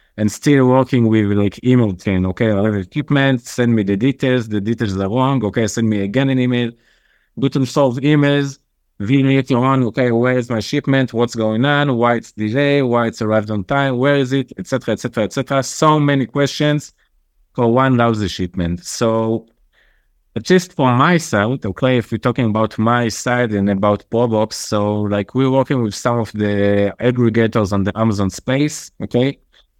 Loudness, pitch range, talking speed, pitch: -16 LUFS, 105-135 Hz, 175 wpm, 120 Hz